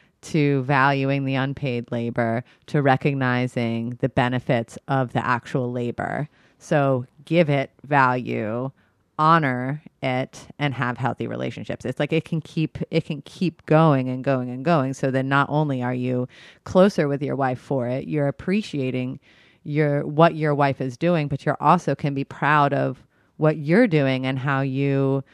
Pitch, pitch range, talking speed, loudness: 135 Hz, 125-150 Hz, 165 wpm, -22 LUFS